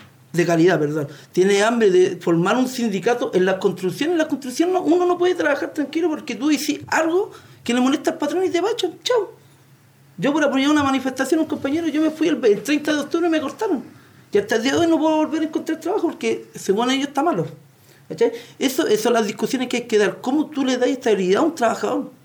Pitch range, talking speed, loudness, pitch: 205-320 Hz, 230 wpm, -20 LUFS, 270 Hz